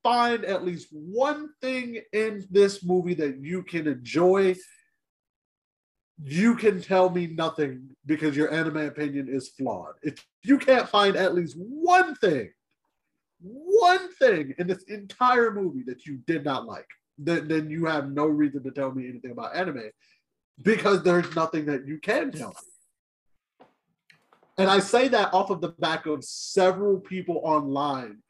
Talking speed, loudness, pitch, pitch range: 155 wpm, -25 LUFS, 180 Hz, 150-215 Hz